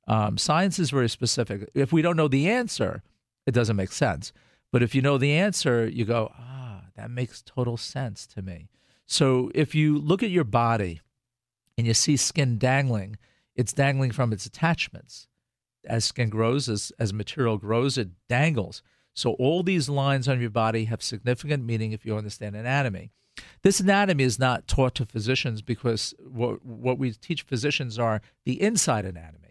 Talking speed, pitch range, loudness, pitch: 175 wpm, 110-140 Hz, -25 LUFS, 125 Hz